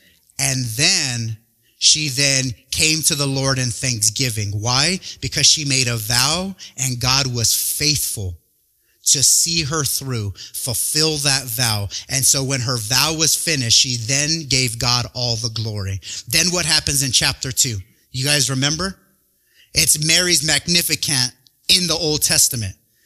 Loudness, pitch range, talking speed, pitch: -16 LUFS, 120-150 Hz, 150 wpm, 135 Hz